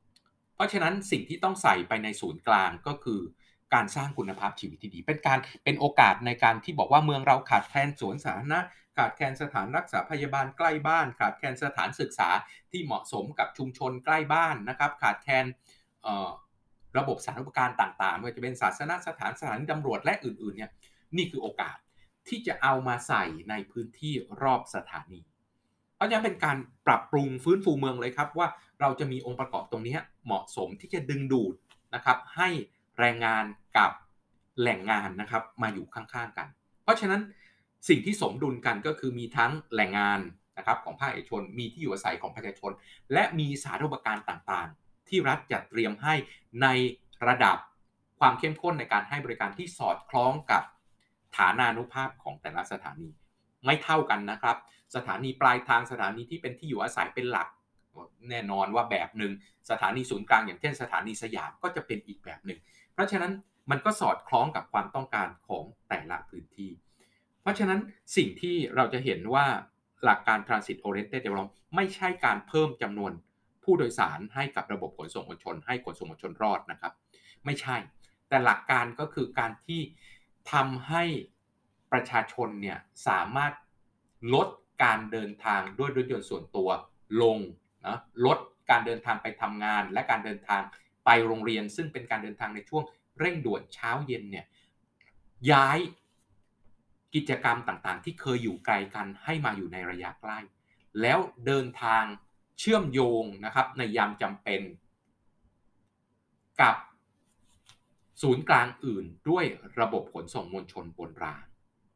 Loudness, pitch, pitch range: -29 LUFS, 125 Hz, 110-145 Hz